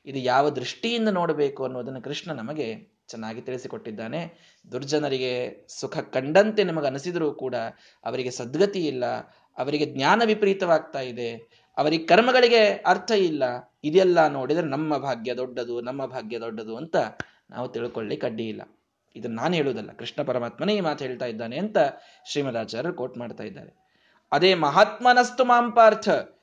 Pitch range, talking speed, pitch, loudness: 125-200 Hz, 125 wpm, 150 Hz, -24 LUFS